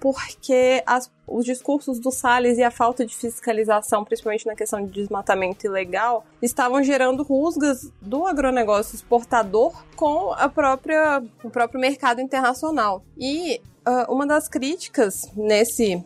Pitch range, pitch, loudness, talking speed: 225-275 Hz, 245 Hz, -22 LUFS, 135 wpm